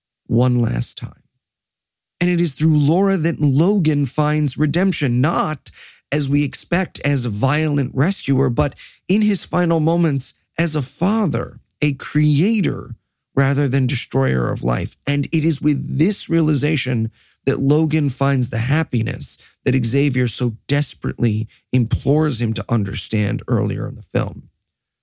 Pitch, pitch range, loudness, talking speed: 140 Hz, 120-155 Hz, -18 LUFS, 140 wpm